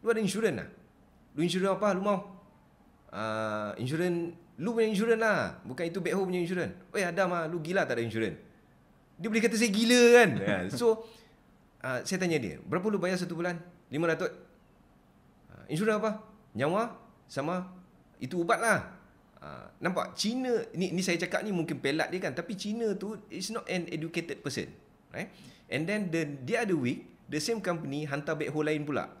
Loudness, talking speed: -30 LUFS, 185 wpm